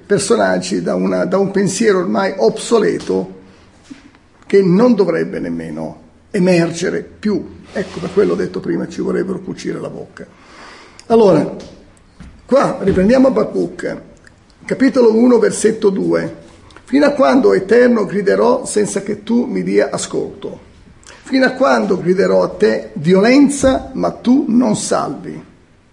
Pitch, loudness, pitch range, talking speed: 205 Hz, -14 LUFS, 170-240 Hz, 125 wpm